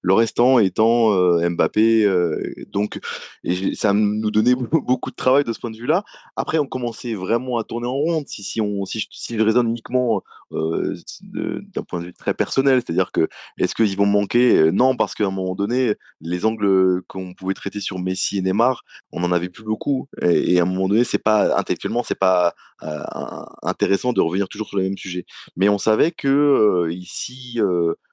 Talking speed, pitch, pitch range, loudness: 205 wpm, 105 Hz, 95-120 Hz, -21 LUFS